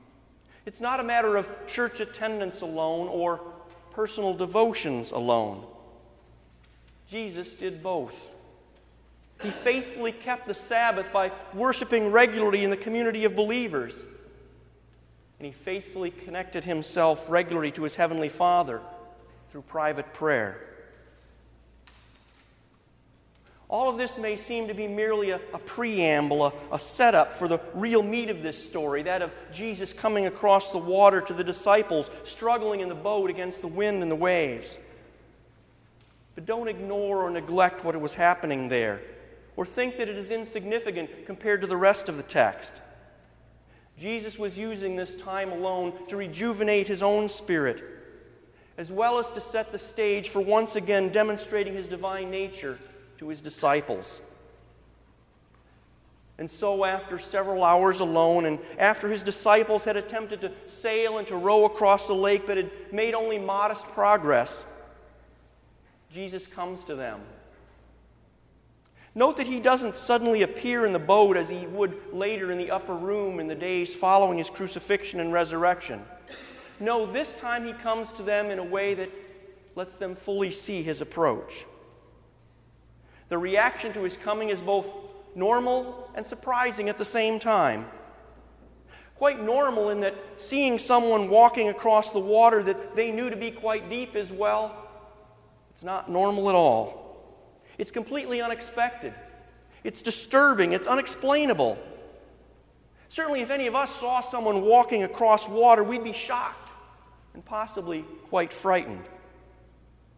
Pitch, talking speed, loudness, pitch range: 200 Hz, 145 wpm, -26 LUFS, 175-225 Hz